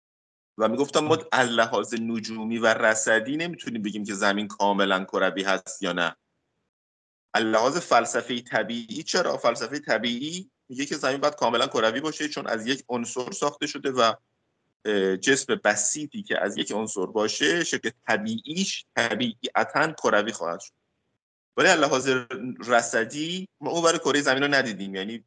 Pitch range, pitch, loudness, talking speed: 105-150 Hz, 125 Hz, -25 LUFS, 145 wpm